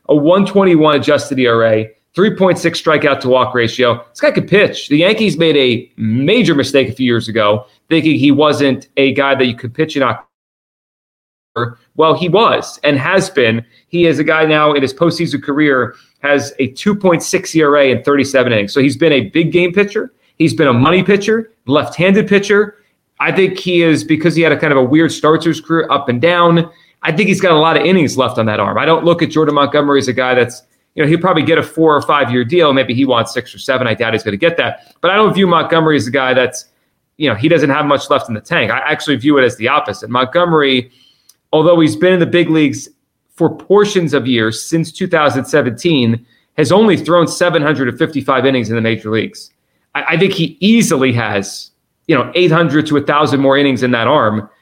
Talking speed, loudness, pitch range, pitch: 220 wpm, -12 LUFS, 130-170 Hz, 150 Hz